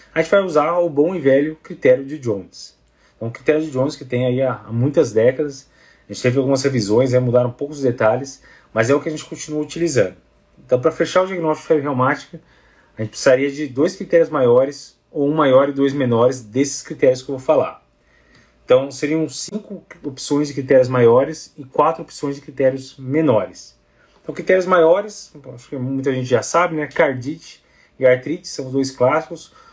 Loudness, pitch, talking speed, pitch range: -18 LUFS, 140 Hz, 190 wpm, 130-160 Hz